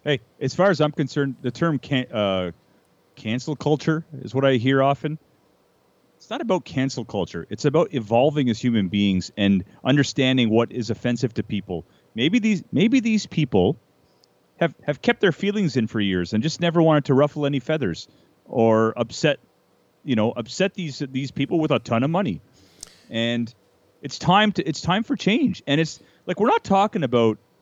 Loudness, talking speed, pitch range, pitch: -22 LUFS, 185 wpm, 115-165 Hz, 135 Hz